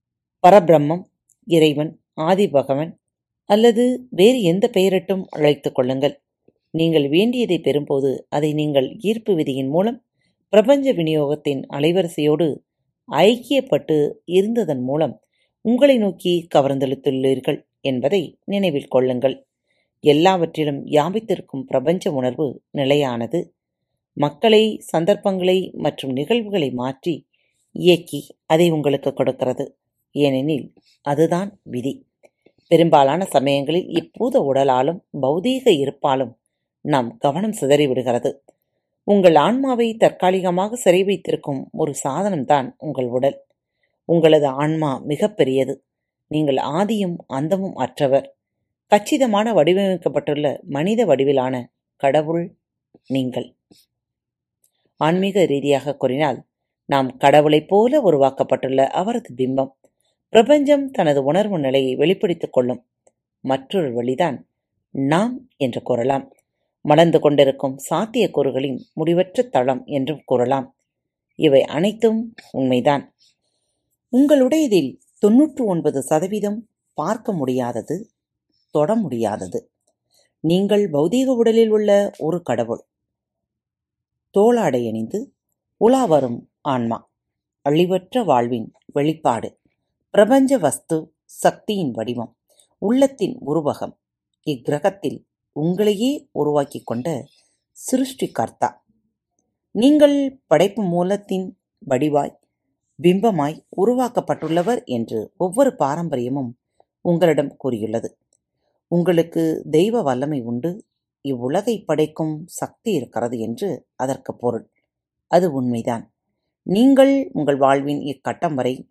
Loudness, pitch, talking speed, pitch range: -19 LUFS, 155 Hz, 85 wpm, 135-200 Hz